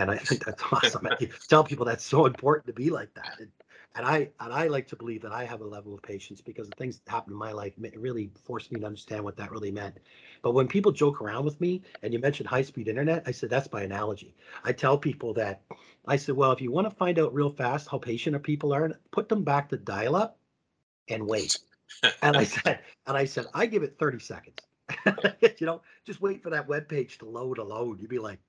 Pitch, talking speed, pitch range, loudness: 130 Hz, 250 wpm, 110-150 Hz, -28 LUFS